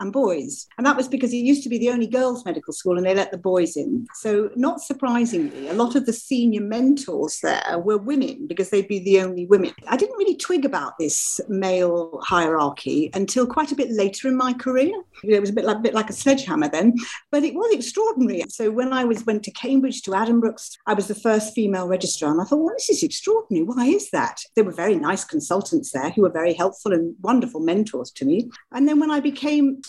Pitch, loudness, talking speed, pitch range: 235 Hz, -21 LUFS, 230 wpm, 195-280 Hz